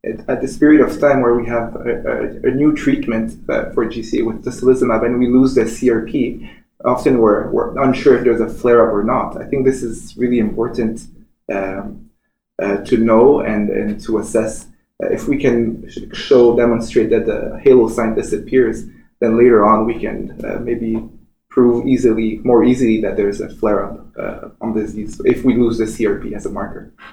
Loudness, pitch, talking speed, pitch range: -16 LUFS, 115 Hz, 190 wpm, 110-125 Hz